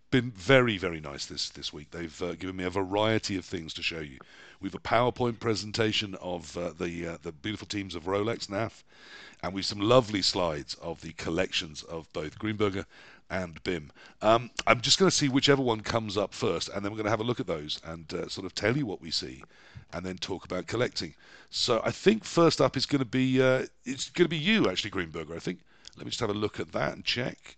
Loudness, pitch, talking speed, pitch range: -29 LUFS, 105 Hz, 240 wpm, 85-125 Hz